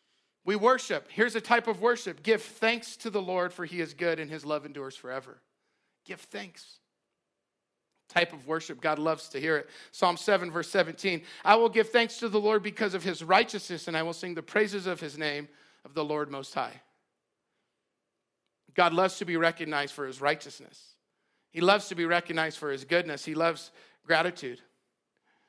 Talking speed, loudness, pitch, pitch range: 185 wpm, -29 LUFS, 175 Hz, 155-210 Hz